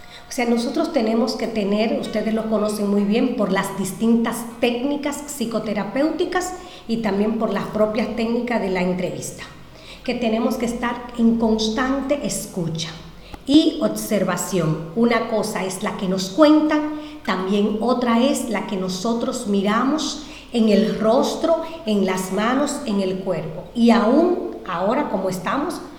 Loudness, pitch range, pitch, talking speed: -21 LUFS, 200-260 Hz, 225 Hz, 145 wpm